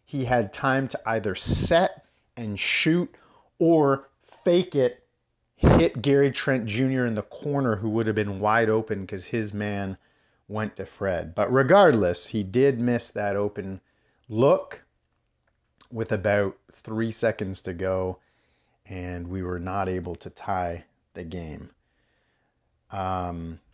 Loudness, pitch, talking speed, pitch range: -25 LUFS, 105 Hz, 135 wpm, 90-120 Hz